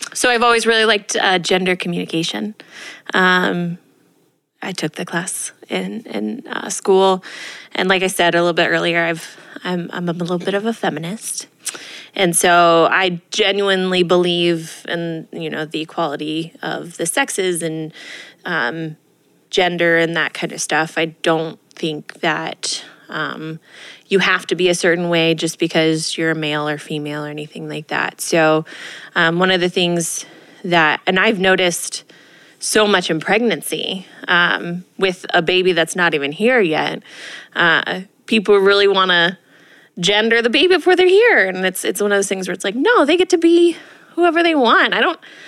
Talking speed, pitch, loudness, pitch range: 175 wpm, 180 Hz, -16 LUFS, 165-200 Hz